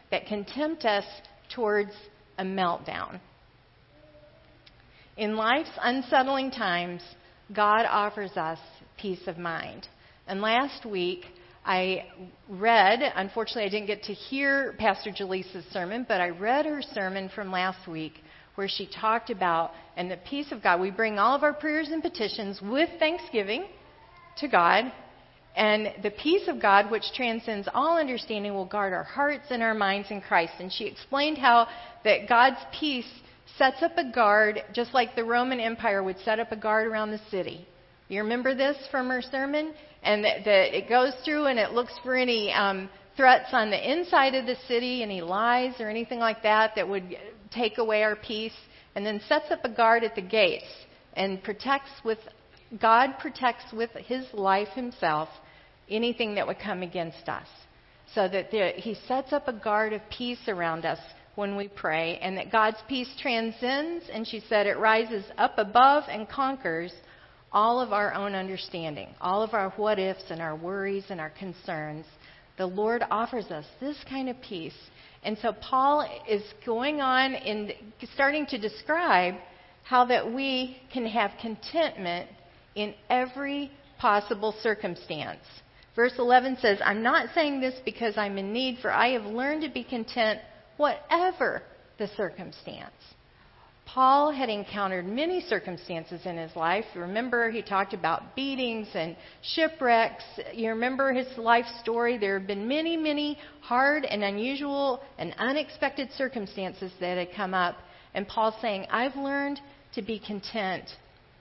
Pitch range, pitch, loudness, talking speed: 195-255 Hz, 220 Hz, -27 LUFS, 160 wpm